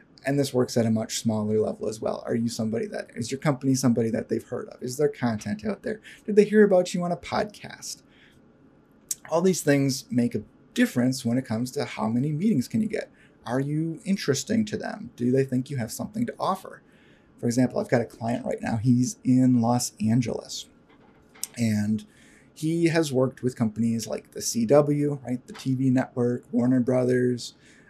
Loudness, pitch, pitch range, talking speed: -26 LUFS, 130 Hz, 120-155 Hz, 195 wpm